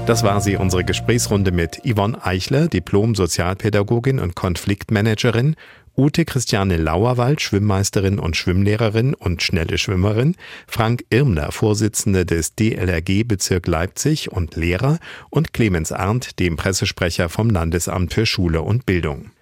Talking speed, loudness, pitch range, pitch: 125 wpm, -19 LUFS, 90-115 Hz, 100 Hz